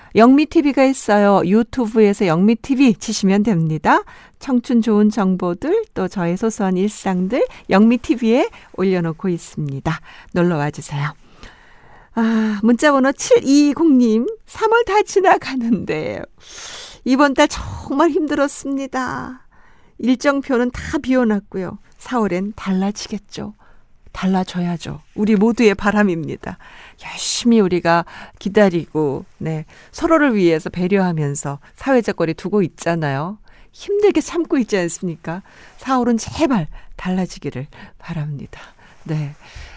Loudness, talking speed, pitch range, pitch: -17 LUFS, 260 characters per minute, 175-270 Hz, 210 Hz